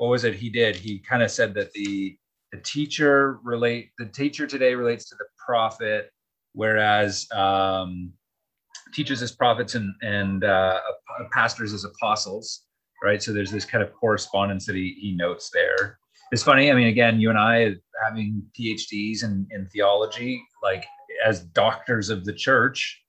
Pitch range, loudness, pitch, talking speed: 100-120 Hz, -23 LUFS, 110 Hz, 165 wpm